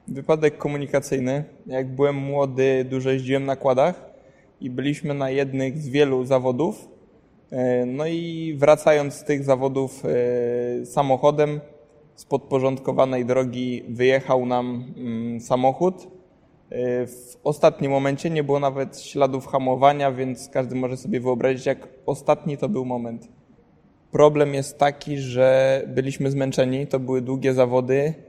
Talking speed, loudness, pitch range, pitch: 120 wpm, -22 LUFS, 130-145 Hz, 135 Hz